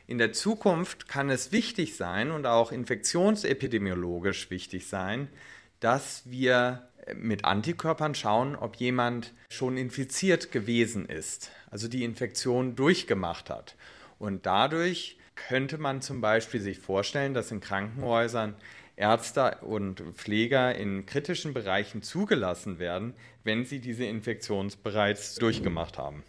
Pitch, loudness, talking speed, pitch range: 120 Hz, -29 LUFS, 125 wpm, 105-135 Hz